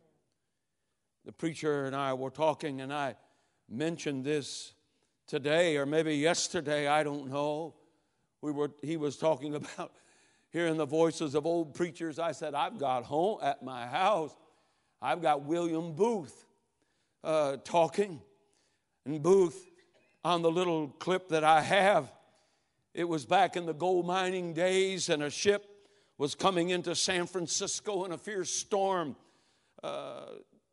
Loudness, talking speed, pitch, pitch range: -31 LUFS, 140 wpm, 165 Hz, 150-180 Hz